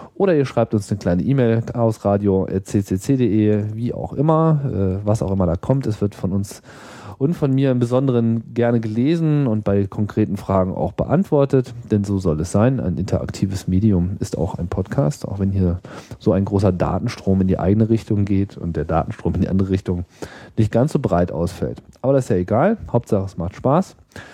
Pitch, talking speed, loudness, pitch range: 105 Hz, 195 wpm, -20 LUFS, 95-125 Hz